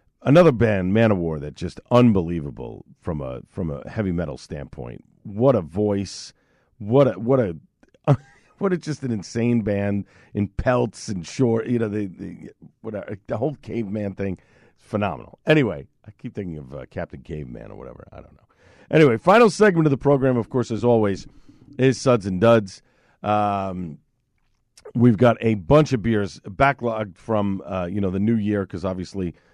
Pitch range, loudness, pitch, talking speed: 95-120 Hz, -21 LUFS, 105 Hz, 175 wpm